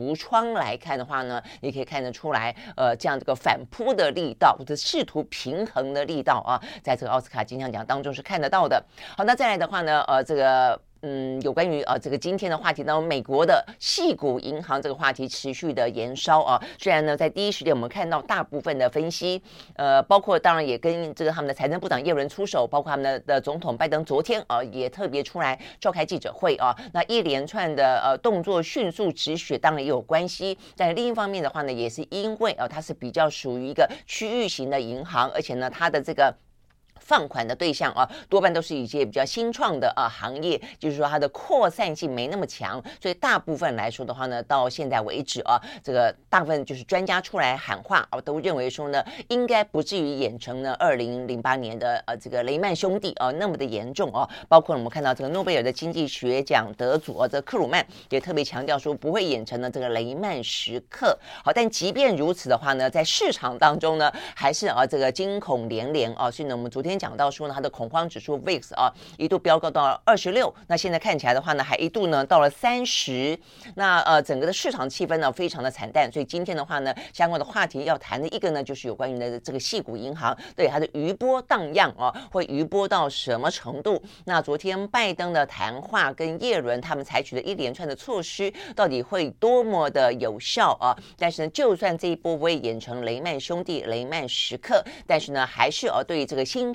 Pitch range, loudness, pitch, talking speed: 130-175 Hz, -25 LUFS, 150 Hz, 330 characters per minute